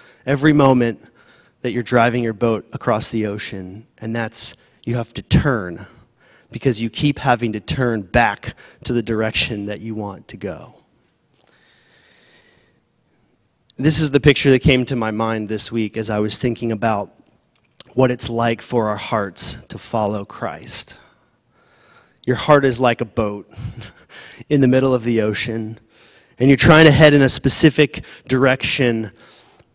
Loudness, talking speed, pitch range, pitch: -17 LUFS, 155 wpm, 110-130 Hz, 120 Hz